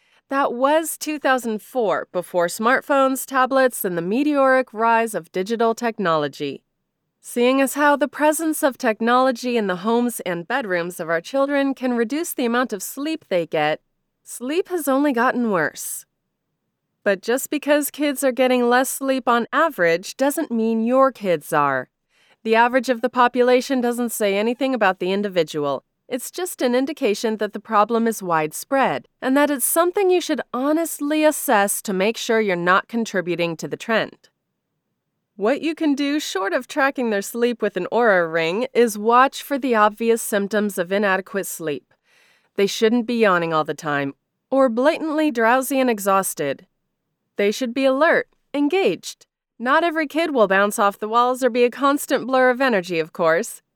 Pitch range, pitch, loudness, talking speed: 200-275 Hz, 240 Hz, -20 LUFS, 165 wpm